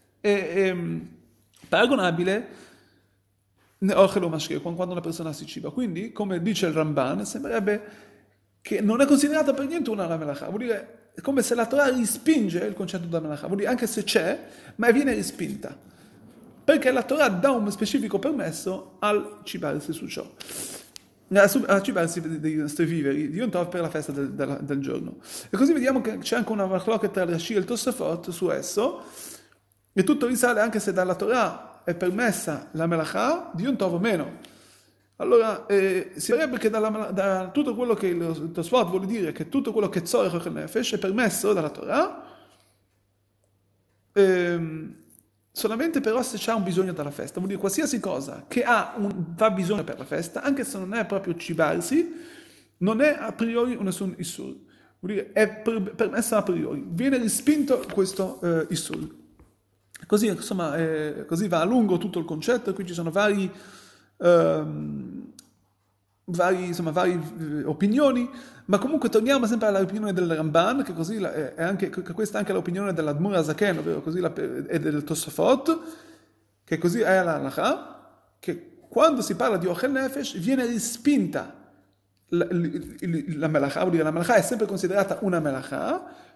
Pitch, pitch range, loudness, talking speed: 195 Hz, 165-235 Hz, -25 LUFS, 165 wpm